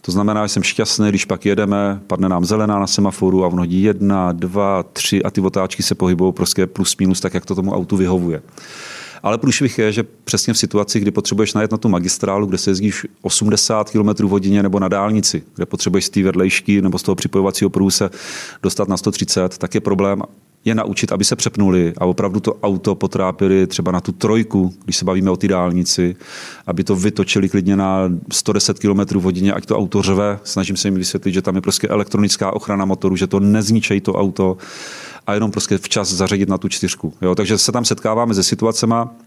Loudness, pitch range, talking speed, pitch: -17 LUFS, 95-105 Hz, 205 wpm, 100 Hz